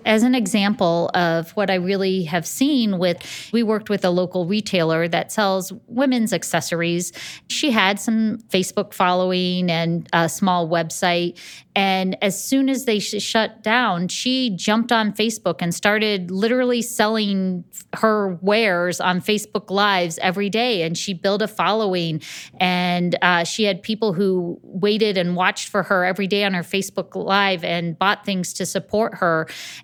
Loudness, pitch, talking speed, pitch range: -20 LUFS, 195 Hz, 160 wpm, 180-215 Hz